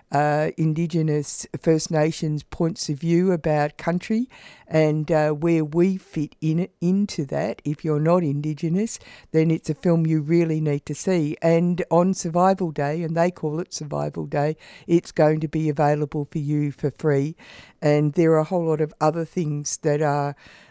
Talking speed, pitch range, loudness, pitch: 175 wpm, 150-170 Hz, -23 LUFS, 155 Hz